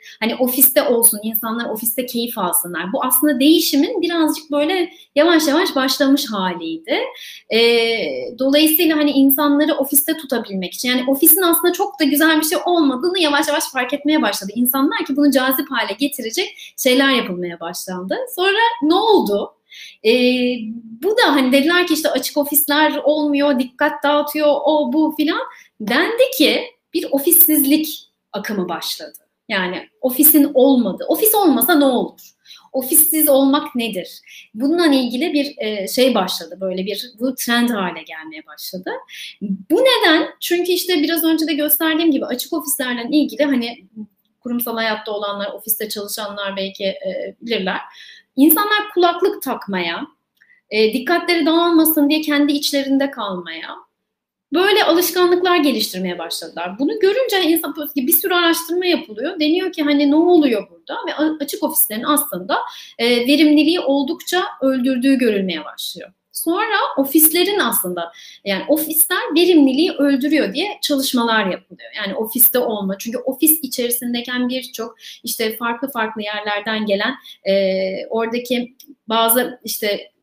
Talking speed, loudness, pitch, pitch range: 130 wpm, -16 LUFS, 280 Hz, 230-320 Hz